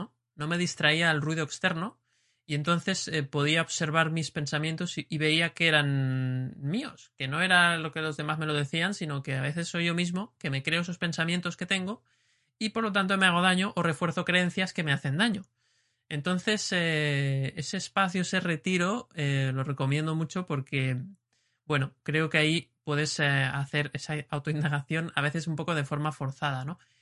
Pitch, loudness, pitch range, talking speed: 160 Hz, -28 LUFS, 145-175 Hz, 190 wpm